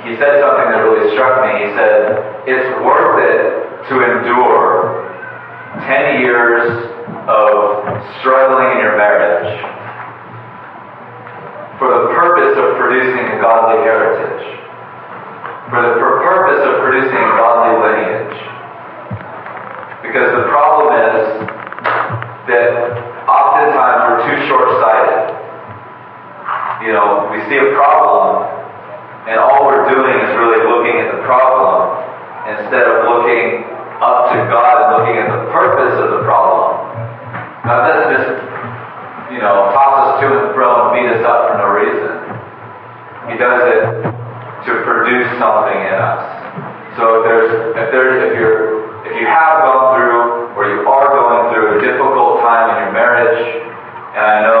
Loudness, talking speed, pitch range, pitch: -11 LUFS, 140 wpm, 115-160 Hz, 120 Hz